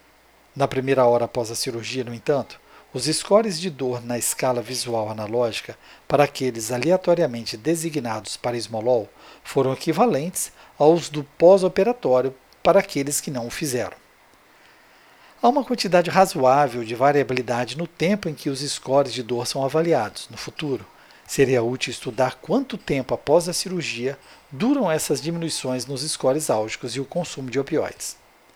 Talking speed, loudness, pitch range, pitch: 145 wpm, -22 LUFS, 125-165 Hz, 140 Hz